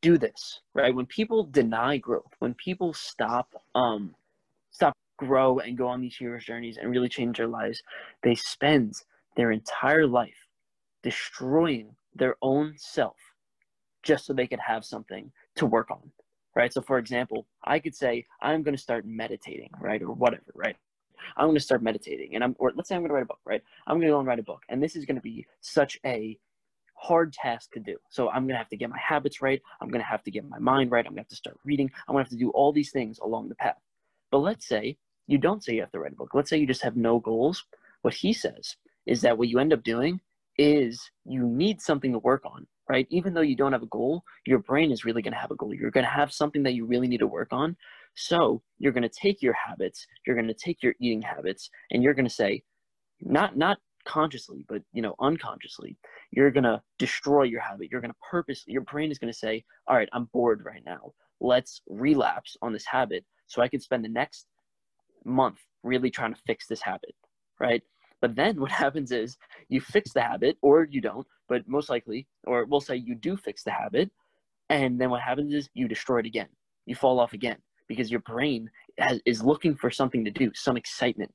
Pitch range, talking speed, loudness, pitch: 120-145 Hz, 225 wpm, -27 LUFS, 130 Hz